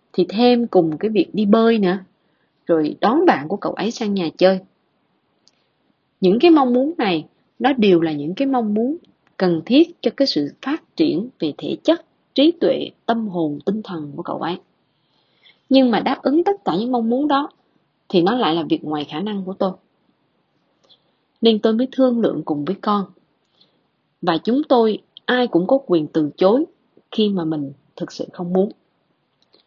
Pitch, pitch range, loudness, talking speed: 210 Hz, 170-255 Hz, -19 LUFS, 185 wpm